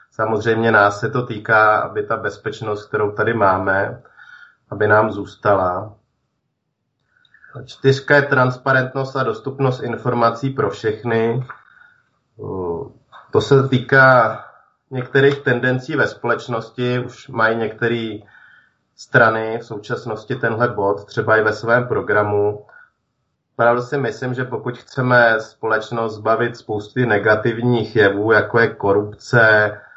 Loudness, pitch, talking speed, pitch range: -17 LUFS, 120 Hz, 115 wpm, 110-130 Hz